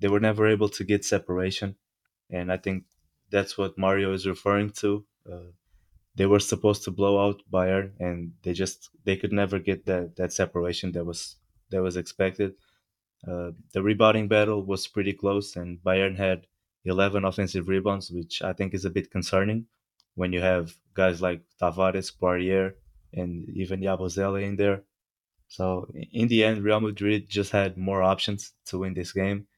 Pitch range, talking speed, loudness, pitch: 90-100 Hz, 170 wpm, -27 LUFS, 95 Hz